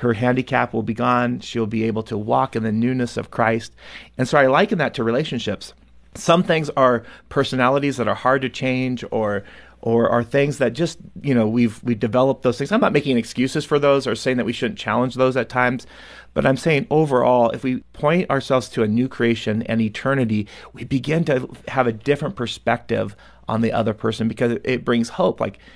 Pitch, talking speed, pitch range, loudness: 125 Hz, 205 wpm, 115-135 Hz, -20 LUFS